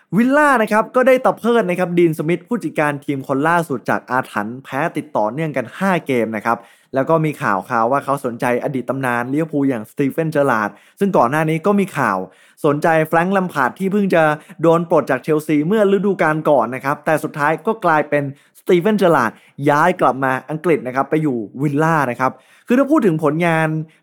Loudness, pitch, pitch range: -17 LUFS, 155 Hz, 135-175 Hz